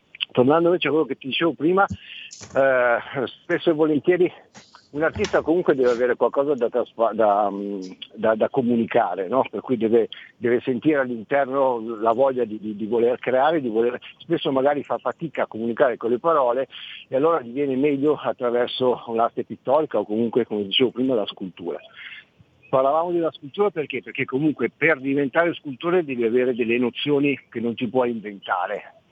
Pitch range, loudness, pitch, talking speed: 115-150 Hz, -22 LUFS, 130 Hz, 170 wpm